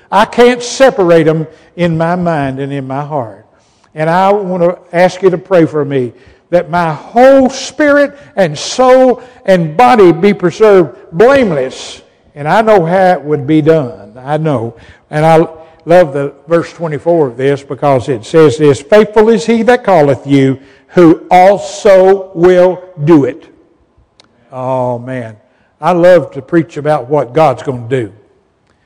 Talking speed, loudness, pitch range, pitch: 160 wpm, -10 LUFS, 140-190 Hz, 165 Hz